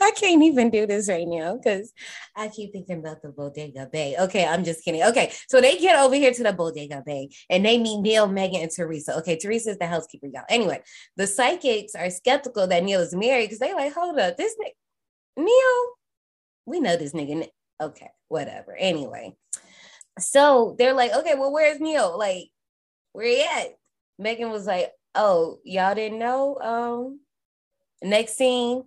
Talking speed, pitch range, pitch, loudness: 185 wpm, 175-270 Hz, 220 Hz, -22 LUFS